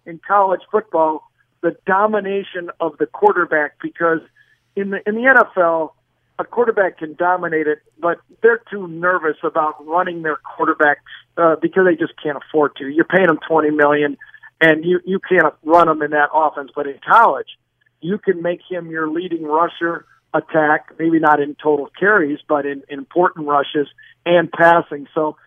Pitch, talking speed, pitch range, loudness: 160 Hz, 170 wpm, 150-180 Hz, -17 LUFS